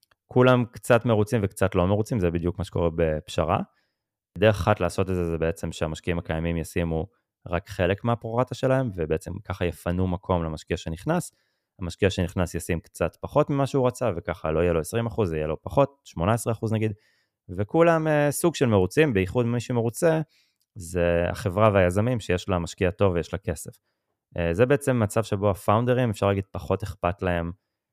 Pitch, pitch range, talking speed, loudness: 95 Hz, 85-115 Hz, 165 wpm, -25 LUFS